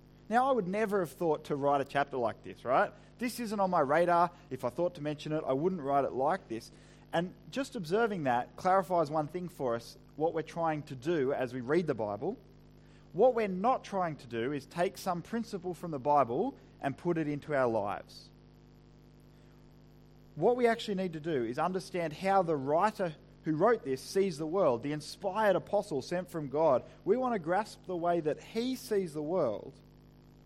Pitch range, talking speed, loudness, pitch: 145-195 Hz, 200 wpm, -32 LUFS, 170 Hz